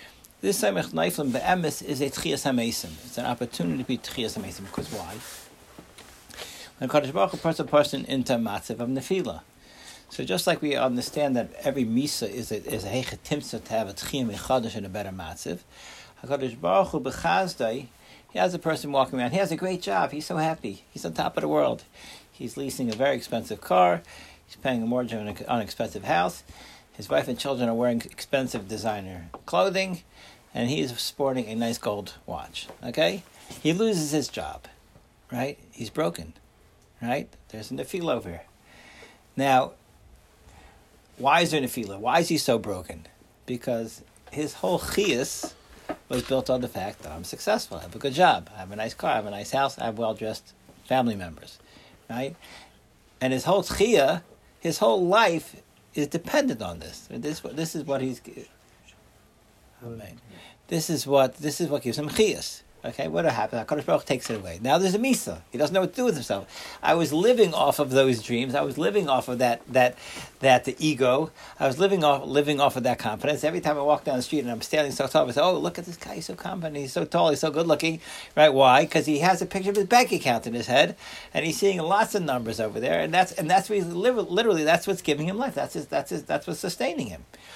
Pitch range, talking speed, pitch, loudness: 115-160 Hz, 205 wpm, 130 Hz, -26 LUFS